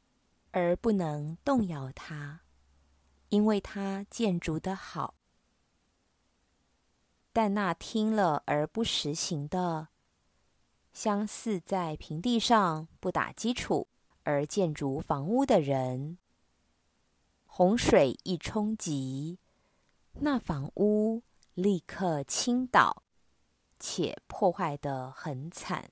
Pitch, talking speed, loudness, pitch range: 175 Hz, 130 characters per minute, -30 LUFS, 145-210 Hz